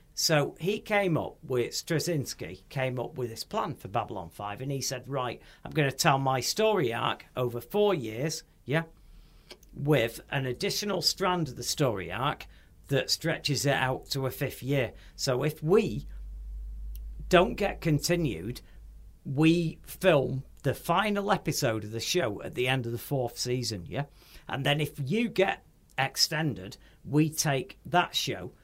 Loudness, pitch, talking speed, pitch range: -29 LUFS, 140 Hz, 160 wpm, 120-165 Hz